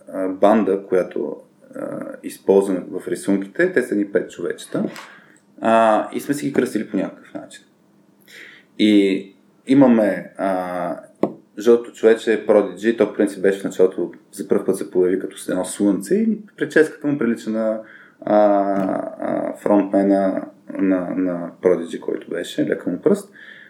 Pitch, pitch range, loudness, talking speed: 100 Hz, 95-115 Hz, -20 LUFS, 145 wpm